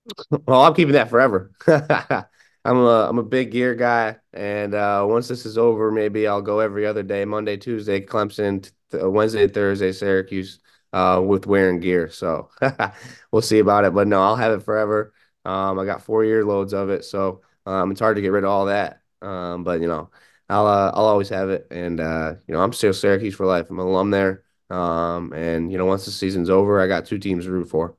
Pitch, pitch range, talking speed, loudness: 100 Hz, 95-105 Hz, 220 wpm, -20 LUFS